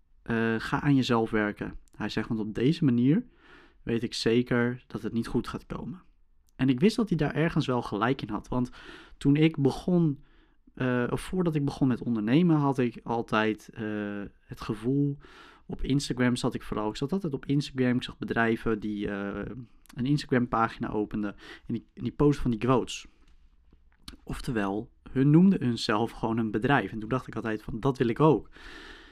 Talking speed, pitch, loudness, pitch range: 190 wpm, 120 Hz, -28 LUFS, 110-140 Hz